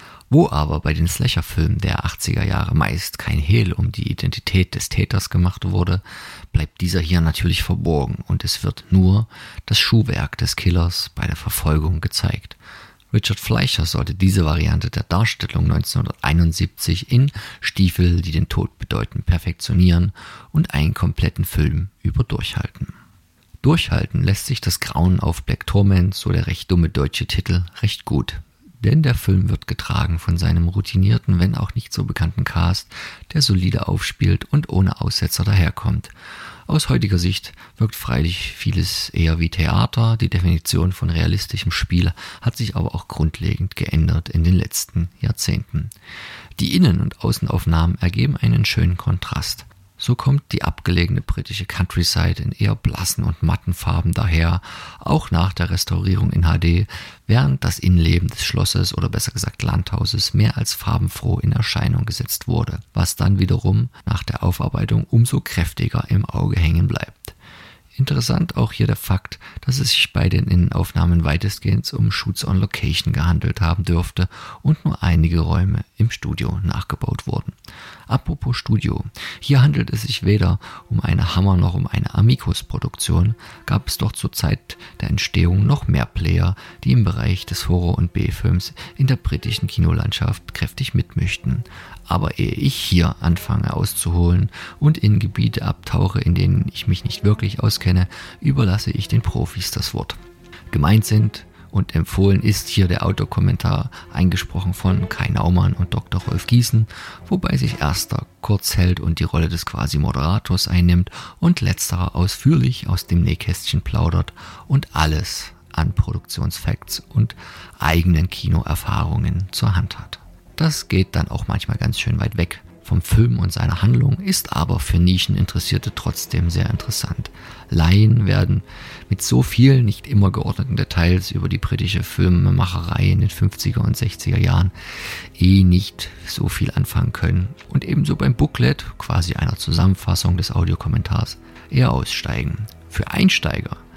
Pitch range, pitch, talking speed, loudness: 90-115 Hz, 100 Hz, 150 wpm, -19 LUFS